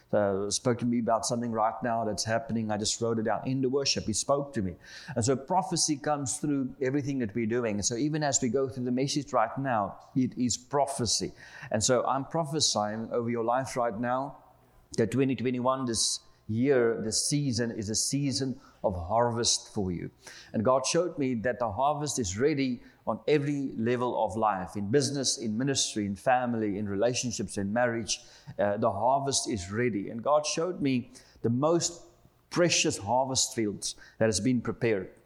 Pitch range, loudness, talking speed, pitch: 115-135 Hz, -29 LUFS, 185 wpm, 125 Hz